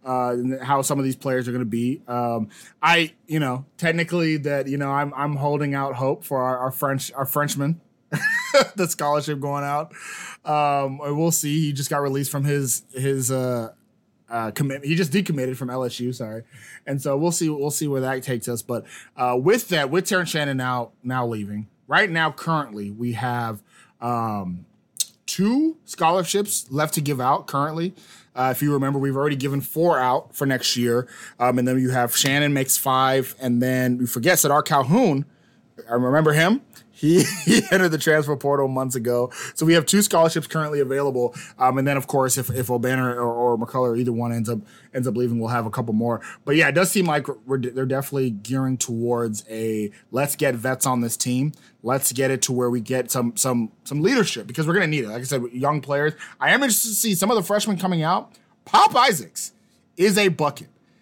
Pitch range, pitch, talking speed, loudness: 125-155 Hz, 135 Hz, 205 wpm, -22 LUFS